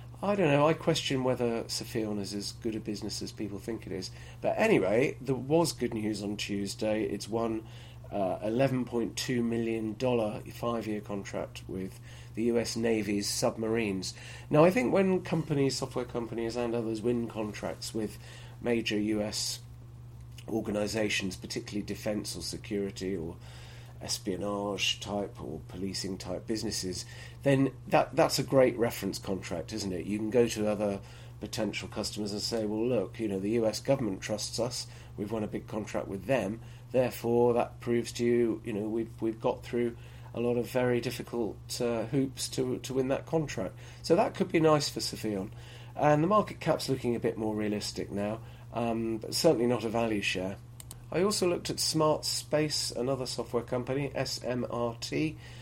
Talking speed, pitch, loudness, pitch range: 165 wpm, 120 Hz, -31 LUFS, 105-125 Hz